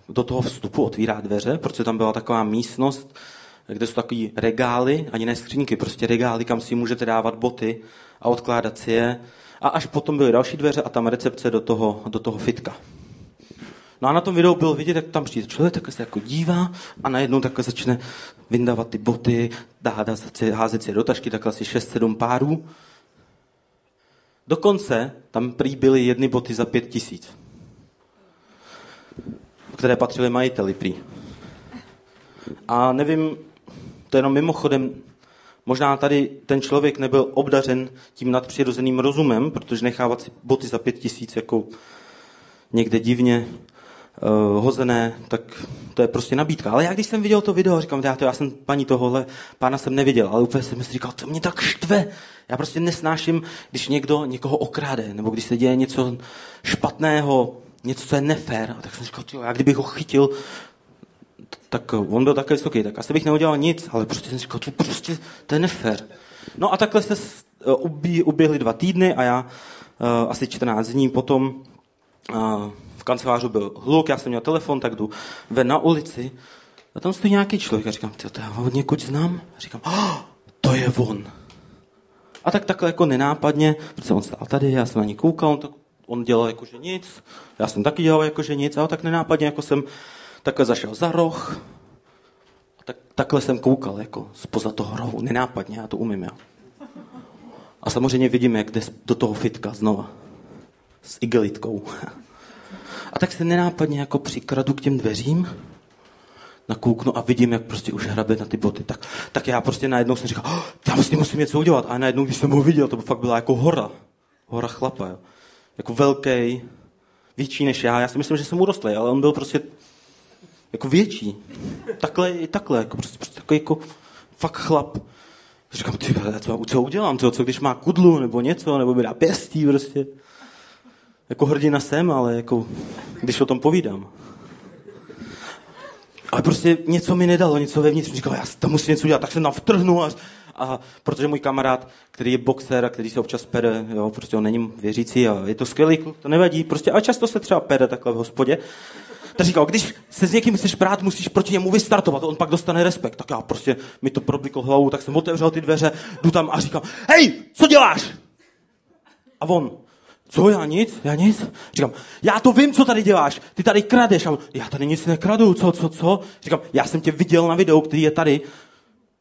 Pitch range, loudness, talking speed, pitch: 120-160 Hz, -21 LUFS, 185 wpm, 135 Hz